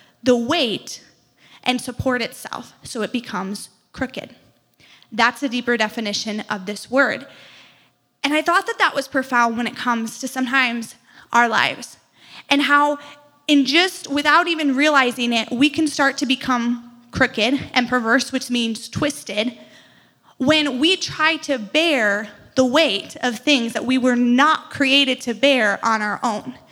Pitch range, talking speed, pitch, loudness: 235-285 Hz, 155 wpm, 255 Hz, -19 LUFS